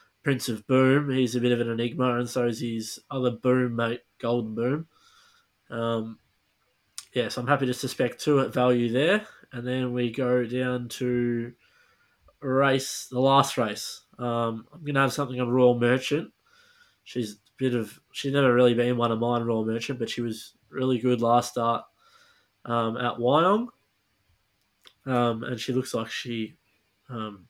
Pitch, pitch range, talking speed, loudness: 125 Hz, 115-135 Hz, 170 wpm, -26 LUFS